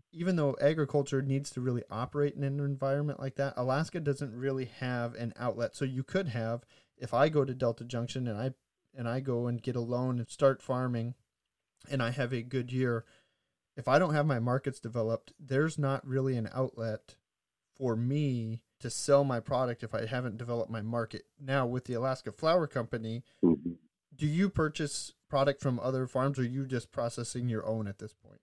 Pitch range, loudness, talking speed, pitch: 120-140 Hz, -33 LUFS, 195 wpm, 130 Hz